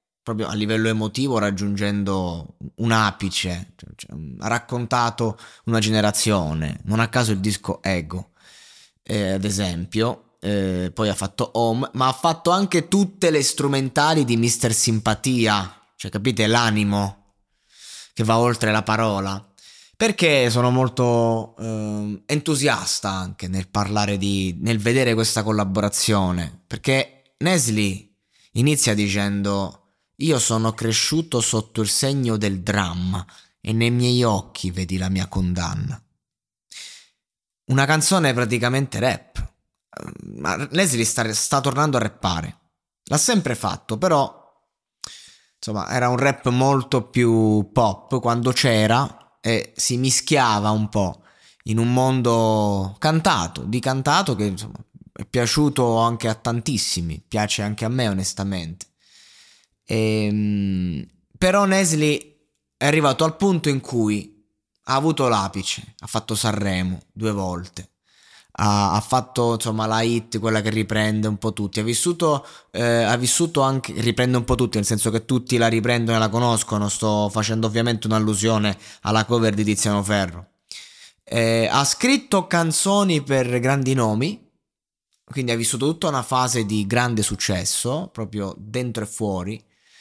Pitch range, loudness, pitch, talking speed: 105-125 Hz, -21 LUFS, 110 Hz, 135 wpm